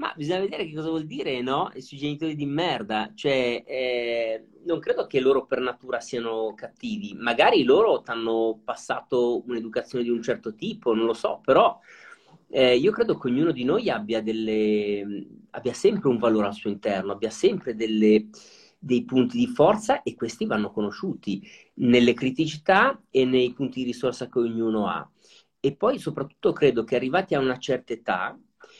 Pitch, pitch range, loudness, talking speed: 125 Hz, 115-145 Hz, -25 LUFS, 170 wpm